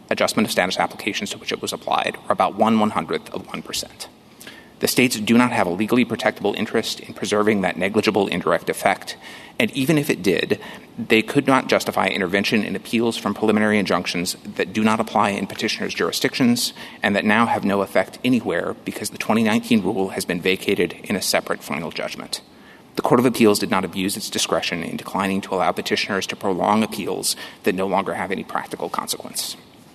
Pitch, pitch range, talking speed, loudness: 110 Hz, 100-140 Hz, 190 wpm, -21 LUFS